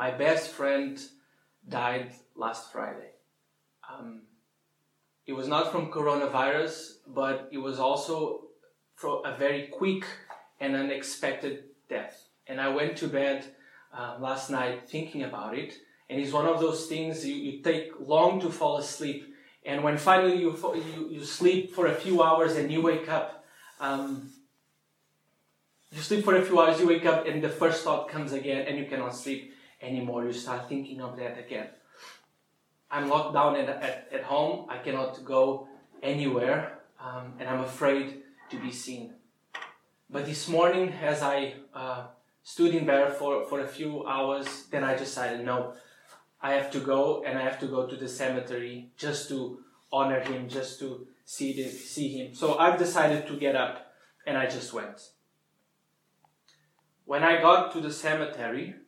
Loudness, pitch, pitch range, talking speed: -29 LUFS, 140 Hz, 130-155 Hz, 165 wpm